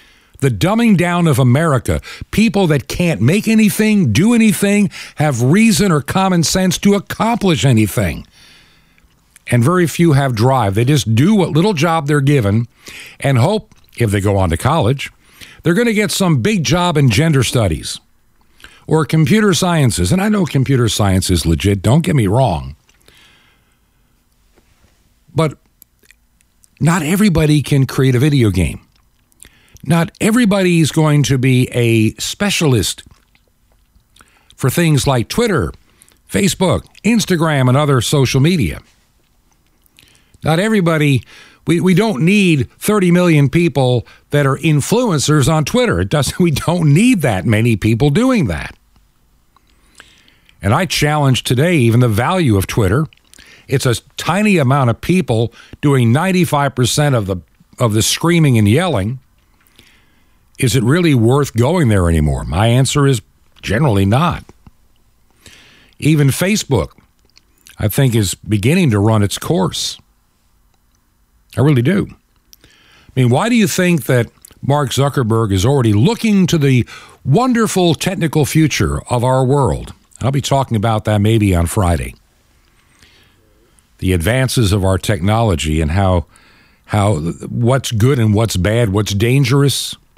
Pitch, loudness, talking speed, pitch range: 135 Hz, -14 LUFS, 140 wpm, 110-165 Hz